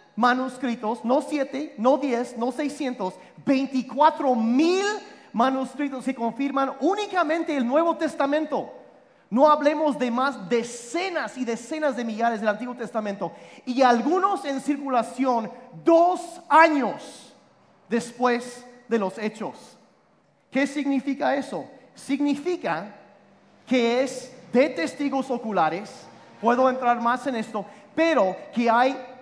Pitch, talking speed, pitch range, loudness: 260 Hz, 115 wpm, 240-290 Hz, -24 LUFS